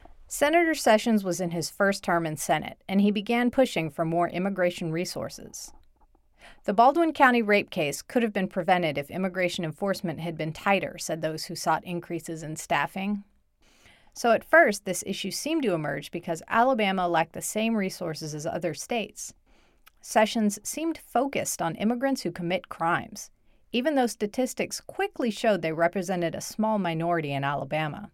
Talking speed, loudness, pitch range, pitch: 160 wpm, -26 LUFS, 170-225 Hz, 190 Hz